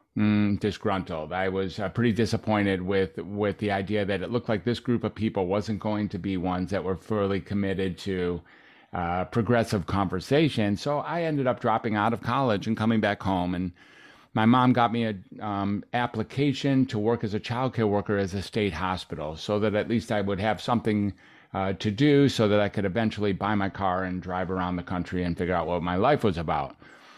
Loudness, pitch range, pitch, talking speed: -27 LUFS, 95-115 Hz, 105 Hz, 210 wpm